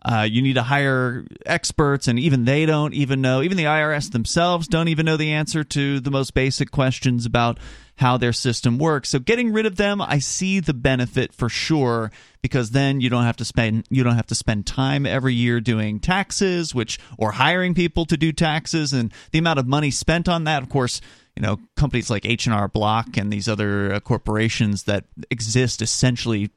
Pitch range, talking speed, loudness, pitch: 115-155 Hz, 210 wpm, -21 LUFS, 130 Hz